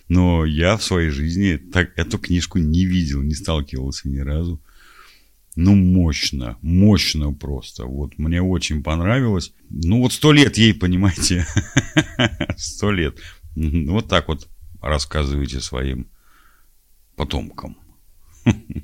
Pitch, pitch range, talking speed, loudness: 85 Hz, 75-95 Hz, 115 wpm, -19 LUFS